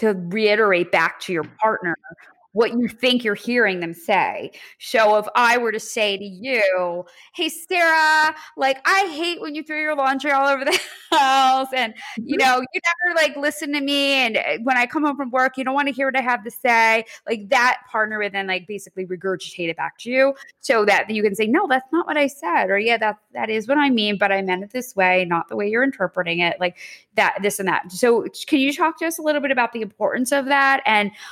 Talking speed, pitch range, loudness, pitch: 240 wpm, 205-280 Hz, -20 LUFS, 245 Hz